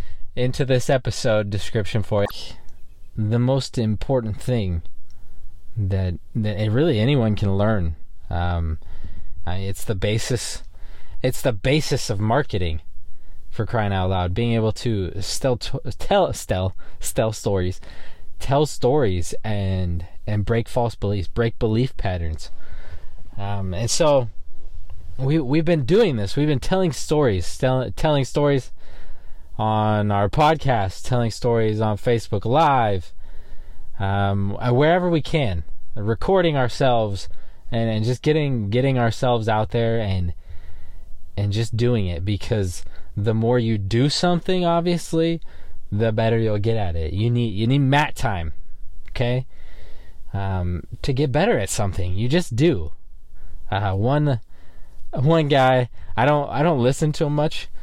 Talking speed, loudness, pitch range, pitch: 135 wpm, -22 LUFS, 85-125 Hz, 105 Hz